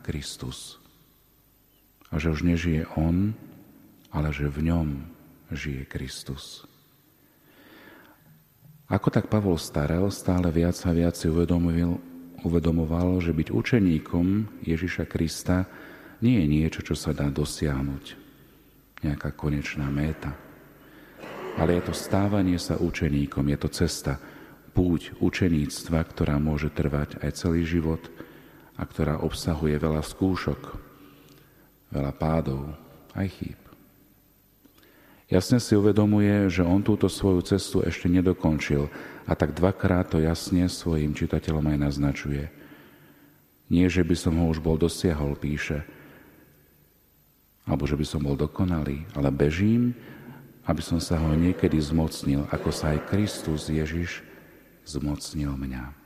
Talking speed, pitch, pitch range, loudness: 120 wpm, 80 Hz, 75-90 Hz, -26 LUFS